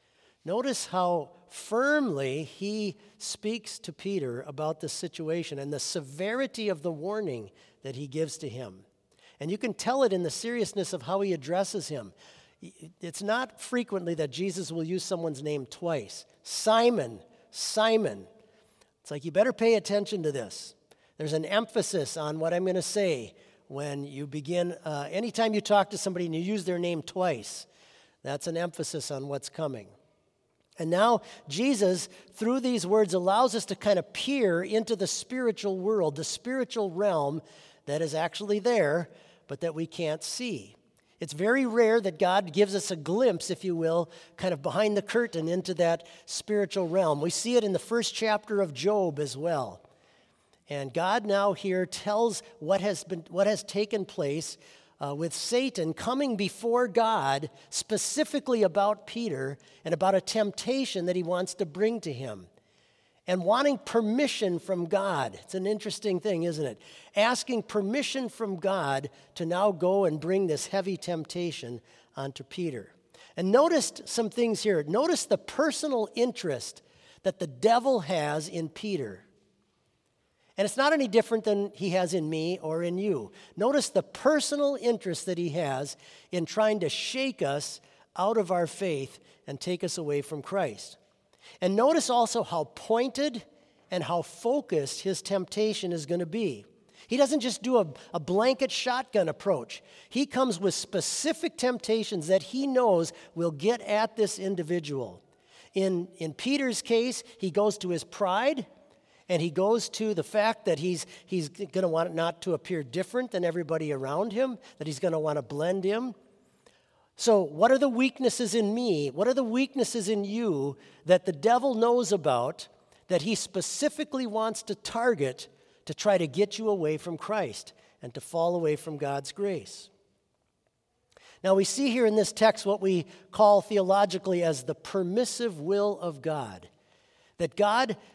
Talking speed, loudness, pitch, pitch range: 165 wpm, -29 LUFS, 190 Hz, 165-220 Hz